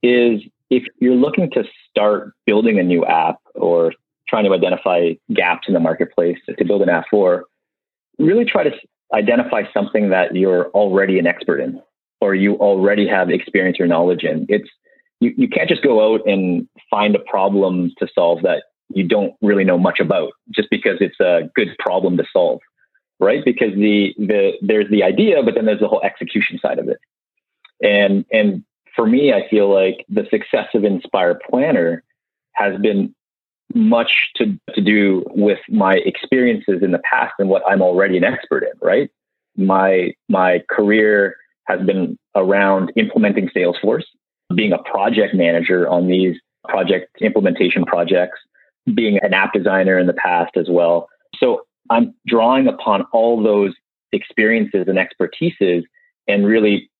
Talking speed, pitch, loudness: 165 wpm, 105 Hz, -16 LUFS